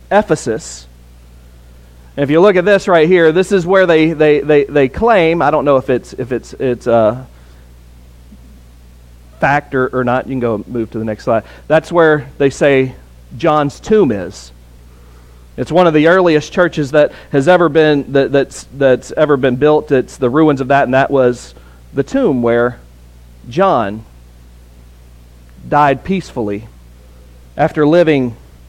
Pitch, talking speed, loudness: 130 Hz, 160 wpm, -13 LUFS